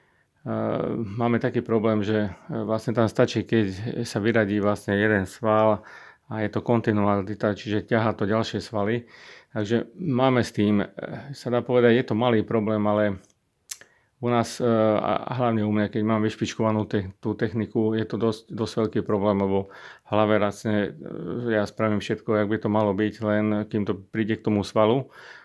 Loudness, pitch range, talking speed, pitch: -24 LUFS, 105-115 Hz, 165 wpm, 110 Hz